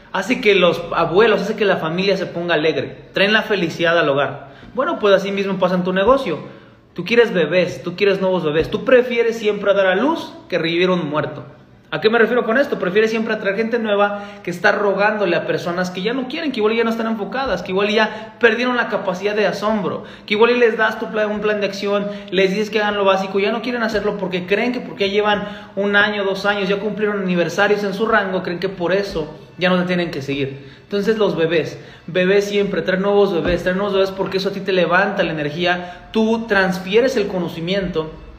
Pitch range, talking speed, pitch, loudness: 180-215 Hz, 225 wpm, 200 Hz, -18 LUFS